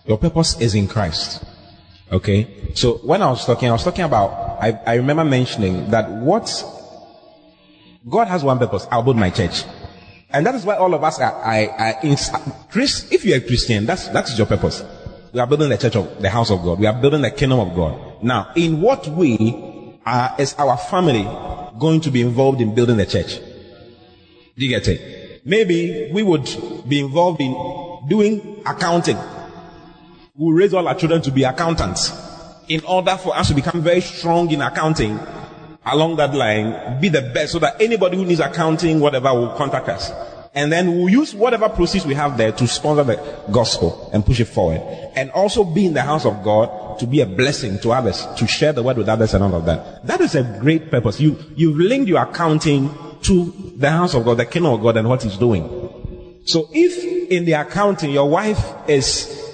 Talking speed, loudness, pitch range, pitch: 200 wpm, -18 LUFS, 115-170 Hz, 145 Hz